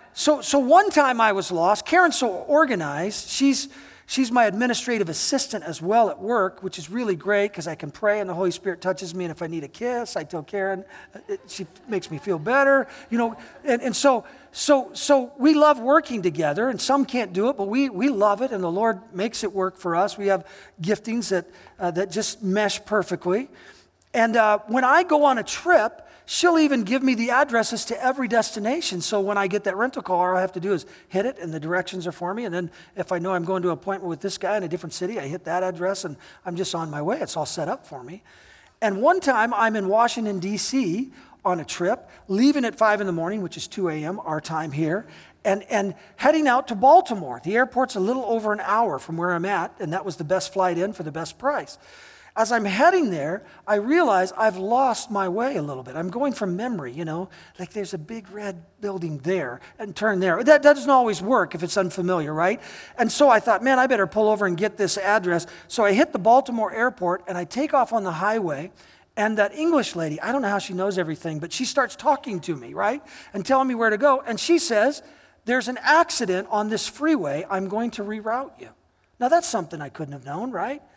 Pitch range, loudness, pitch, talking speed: 185-255 Hz, -22 LUFS, 210 Hz, 235 wpm